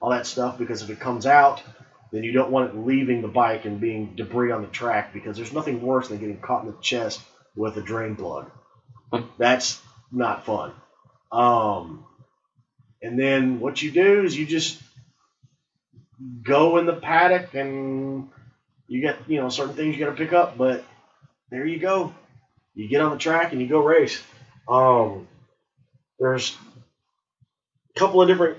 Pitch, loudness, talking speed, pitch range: 130 Hz, -22 LUFS, 175 wpm, 120-150 Hz